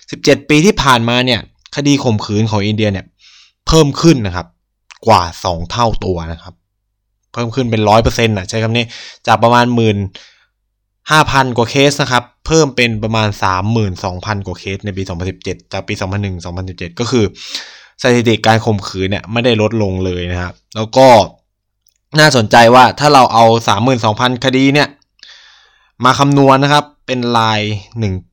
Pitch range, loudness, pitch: 100-125 Hz, -12 LUFS, 110 Hz